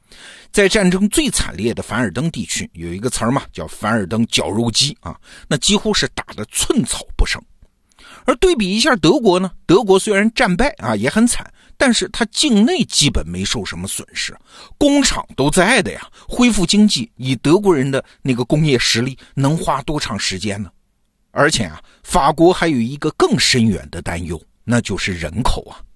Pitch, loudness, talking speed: 140 Hz, -16 LUFS, 270 characters per minute